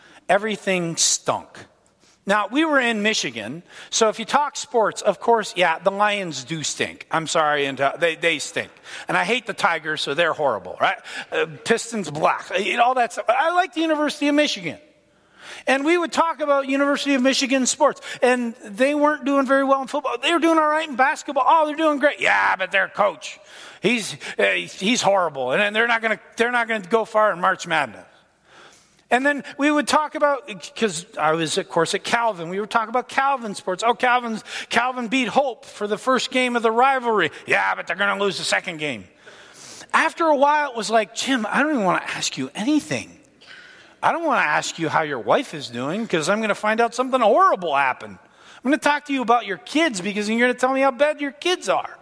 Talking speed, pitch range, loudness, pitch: 215 wpm, 205-280 Hz, -21 LUFS, 240 Hz